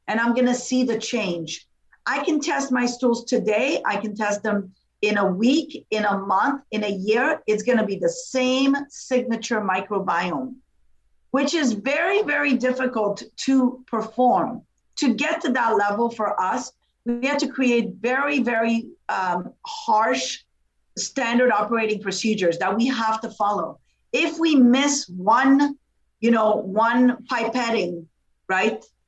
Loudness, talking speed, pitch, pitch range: -22 LUFS, 150 wpm, 240 Hz, 210-265 Hz